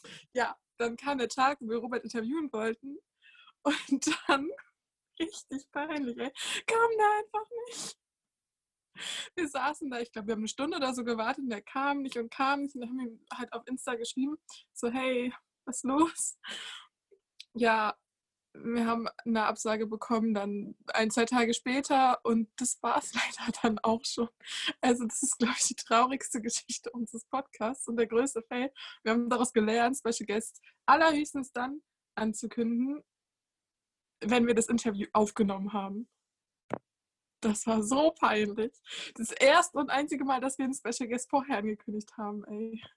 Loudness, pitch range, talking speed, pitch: -31 LUFS, 225-275 Hz, 160 wpm, 245 Hz